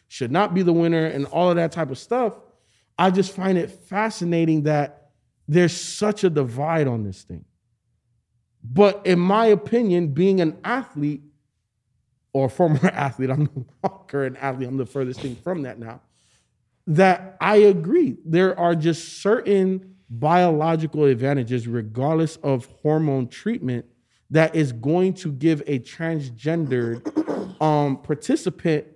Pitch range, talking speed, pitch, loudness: 135-185 Hz, 145 wpm, 155 Hz, -21 LUFS